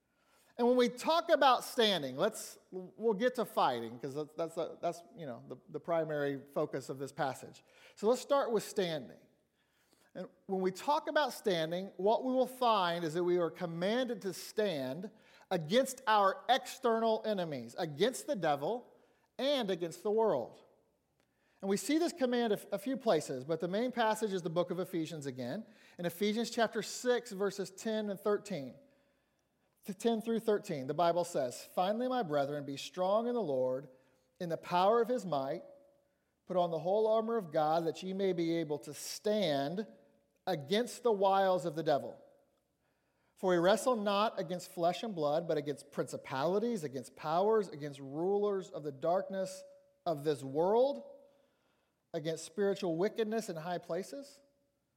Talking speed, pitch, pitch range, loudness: 165 wpm, 195 Hz, 165-230 Hz, -34 LUFS